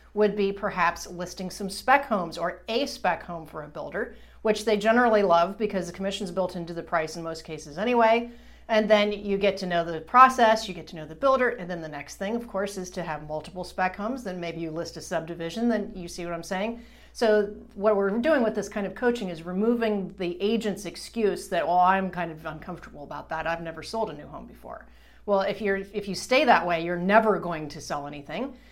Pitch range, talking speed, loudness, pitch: 170-215 Hz, 230 wpm, -26 LUFS, 195 Hz